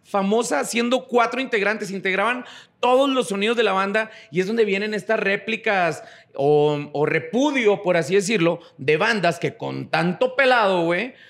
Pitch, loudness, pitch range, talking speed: 205 Hz, -21 LUFS, 170-230 Hz, 160 wpm